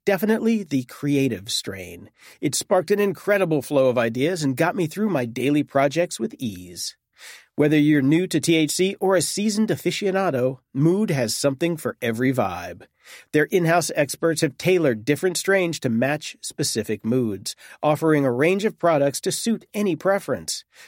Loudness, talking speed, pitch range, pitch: -22 LUFS, 160 wpm, 135-185 Hz, 155 Hz